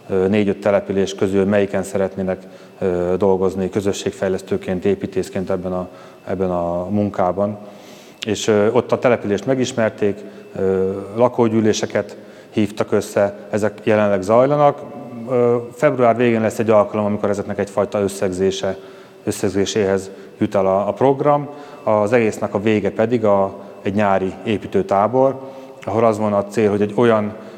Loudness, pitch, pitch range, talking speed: -18 LUFS, 105 Hz, 95-110 Hz, 120 wpm